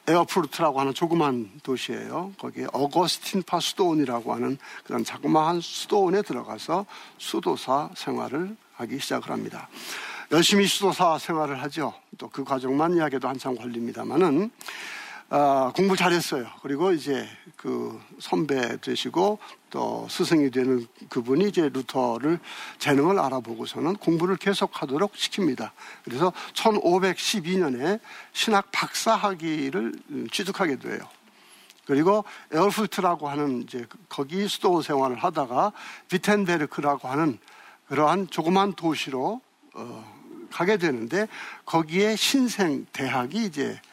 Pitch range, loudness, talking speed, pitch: 135-190 Hz, -25 LUFS, 295 characters per minute, 165 Hz